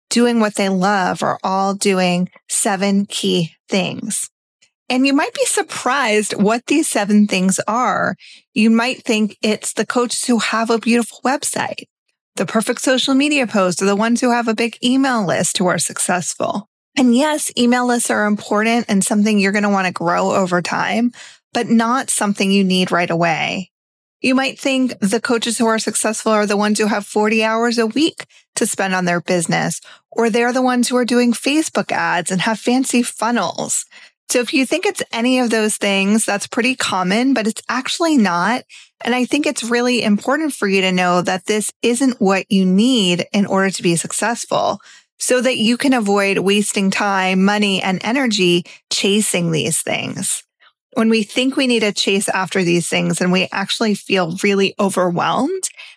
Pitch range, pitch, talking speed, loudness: 195-245 Hz, 215 Hz, 185 wpm, -17 LUFS